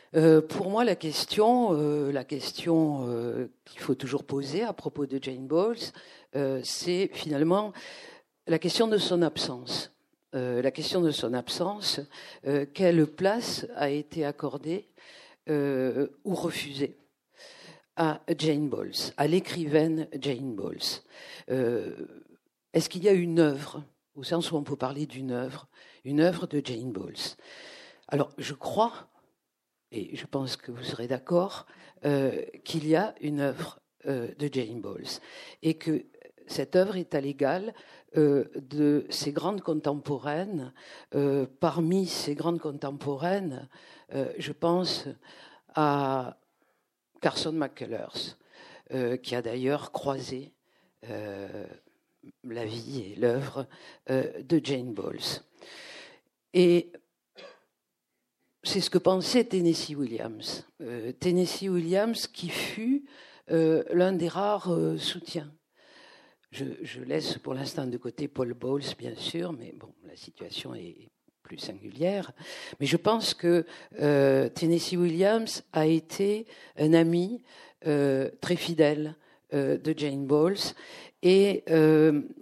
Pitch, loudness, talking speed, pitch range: 155 Hz, -28 LUFS, 125 wpm, 140-175 Hz